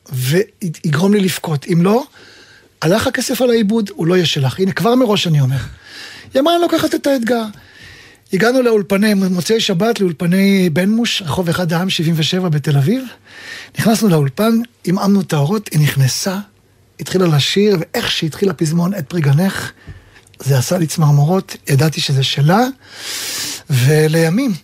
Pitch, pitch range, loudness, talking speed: 185 Hz, 155-225 Hz, -15 LUFS, 145 wpm